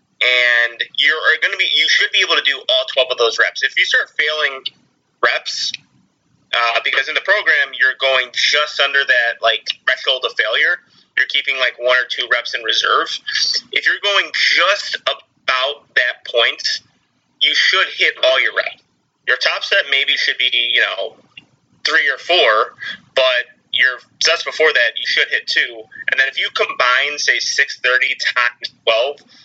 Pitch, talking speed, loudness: 140 Hz, 175 wpm, -15 LUFS